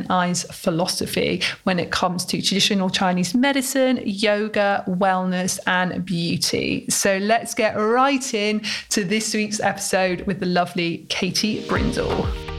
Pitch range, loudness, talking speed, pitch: 180-220 Hz, -21 LUFS, 130 wpm, 195 Hz